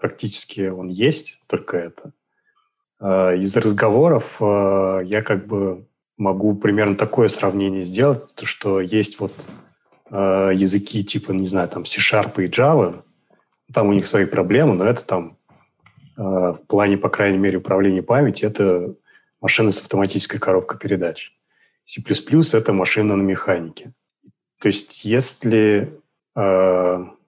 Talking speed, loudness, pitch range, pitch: 125 wpm, -19 LUFS, 95-105 Hz, 100 Hz